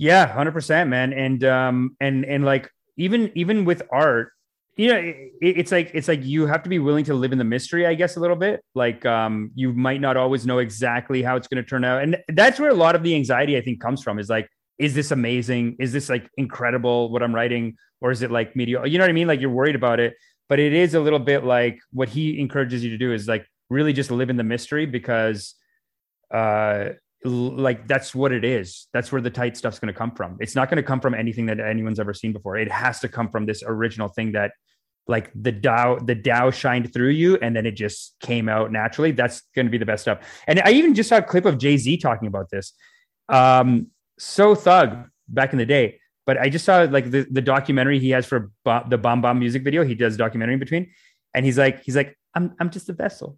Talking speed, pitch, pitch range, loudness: 245 wpm, 130 Hz, 120-150 Hz, -21 LUFS